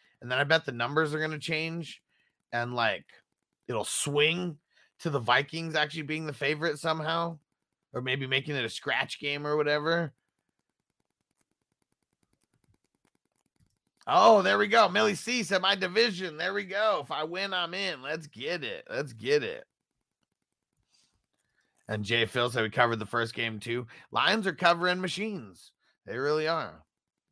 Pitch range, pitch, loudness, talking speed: 135-180 Hz, 155 Hz, -28 LUFS, 155 wpm